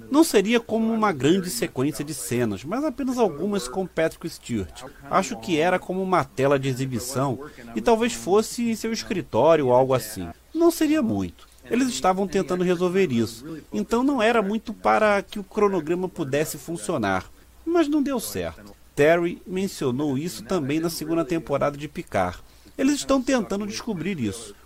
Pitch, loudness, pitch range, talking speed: 180 Hz, -24 LUFS, 145-220 Hz, 165 wpm